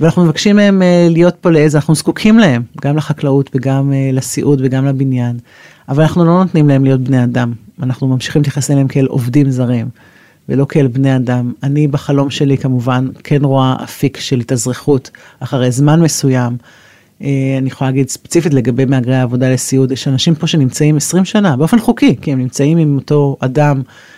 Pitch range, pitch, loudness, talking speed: 130-155 Hz, 140 Hz, -12 LUFS, 175 wpm